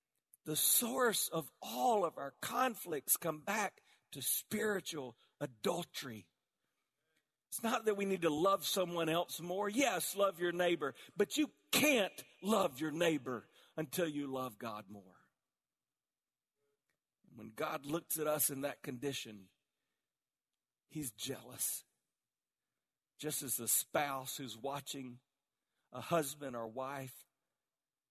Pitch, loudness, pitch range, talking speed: 145 Hz, -37 LUFS, 130-175 Hz, 120 wpm